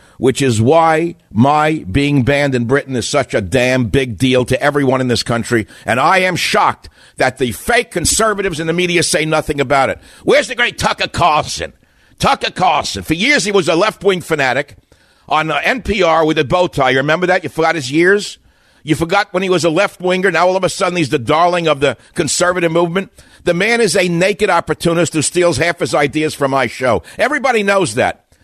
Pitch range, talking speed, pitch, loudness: 140-180 Hz, 205 wpm, 160 Hz, -14 LUFS